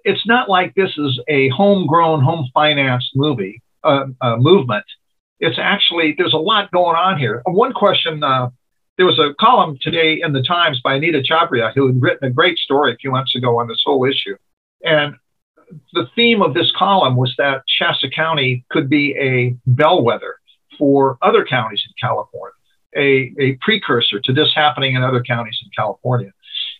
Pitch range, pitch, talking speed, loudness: 130-165 Hz, 140 Hz, 175 wpm, -15 LUFS